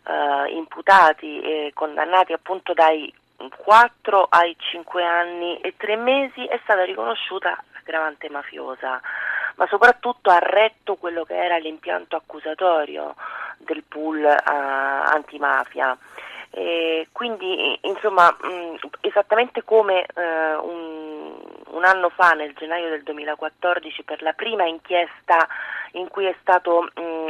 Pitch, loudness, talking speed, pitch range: 170 Hz, -20 LUFS, 120 wpm, 155-190 Hz